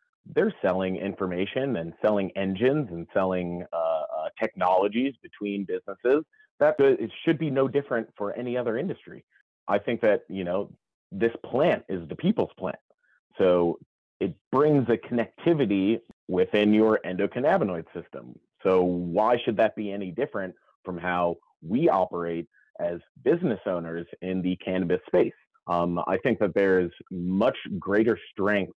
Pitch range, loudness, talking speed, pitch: 90-115 Hz, -26 LUFS, 145 wpm, 95 Hz